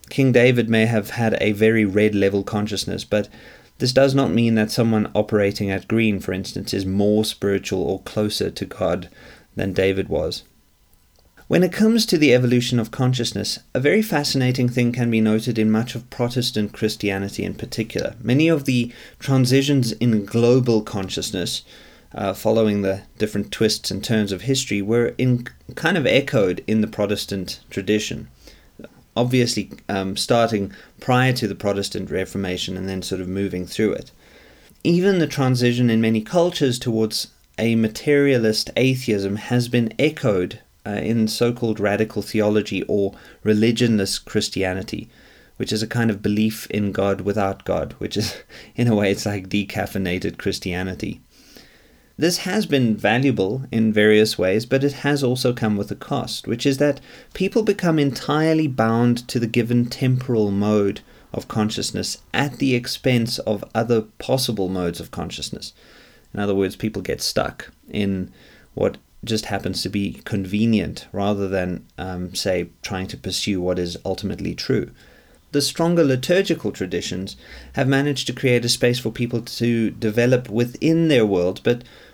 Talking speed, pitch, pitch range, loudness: 155 wpm, 110 Hz, 100-125 Hz, -21 LUFS